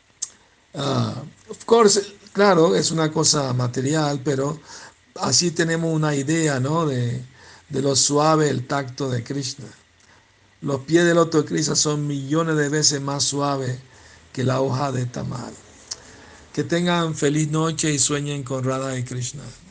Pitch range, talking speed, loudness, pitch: 130-155 Hz, 145 wpm, -21 LUFS, 145 Hz